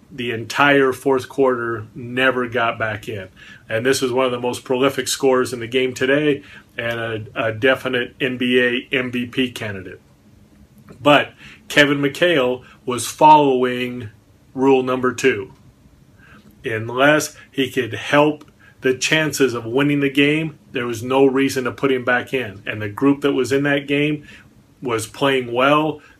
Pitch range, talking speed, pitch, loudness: 120-140 Hz, 150 wpm, 130 Hz, -18 LUFS